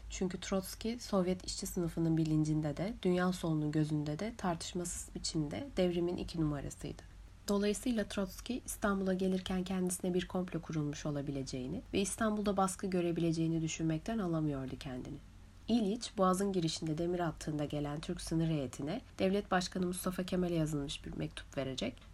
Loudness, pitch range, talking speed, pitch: -36 LUFS, 150-190 Hz, 135 wpm, 175 Hz